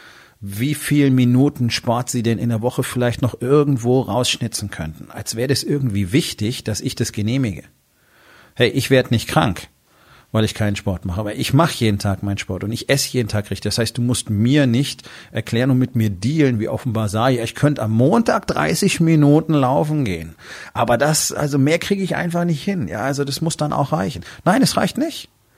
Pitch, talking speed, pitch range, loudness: 125 Hz, 210 wpm, 110-145 Hz, -19 LUFS